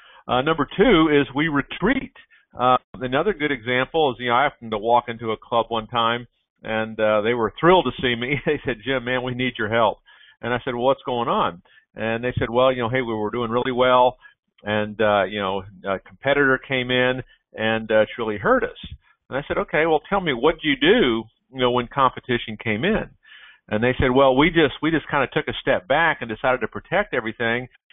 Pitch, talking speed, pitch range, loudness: 125 Hz, 230 wpm, 115-135 Hz, -21 LUFS